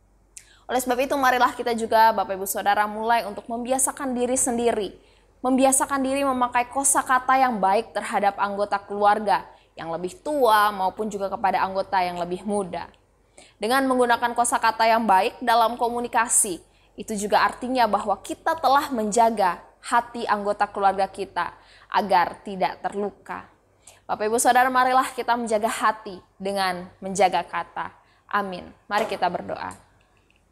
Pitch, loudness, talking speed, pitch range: 215 Hz, -23 LUFS, 135 wpm, 195-245 Hz